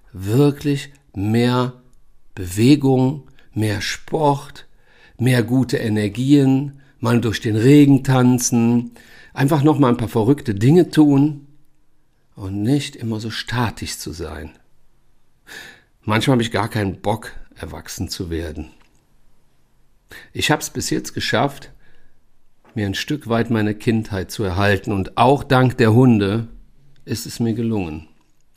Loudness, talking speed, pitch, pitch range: -18 LUFS, 125 wpm, 120 Hz, 110-140 Hz